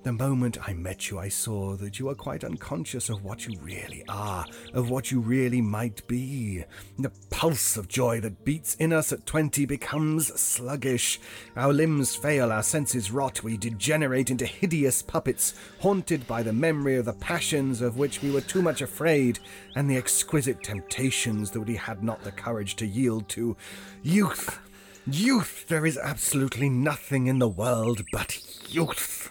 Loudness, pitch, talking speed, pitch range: -27 LUFS, 125 Hz, 170 wpm, 110-140 Hz